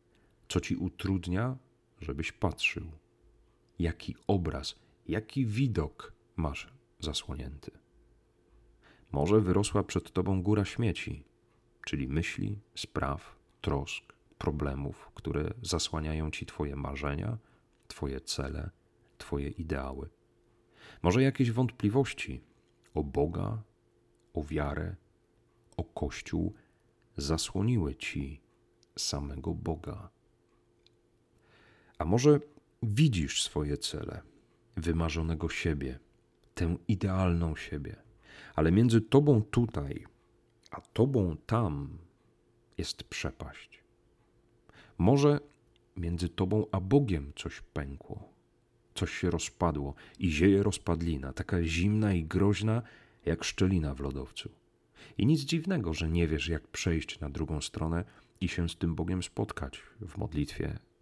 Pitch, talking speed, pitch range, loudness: 90 Hz, 100 wpm, 80-115 Hz, -32 LUFS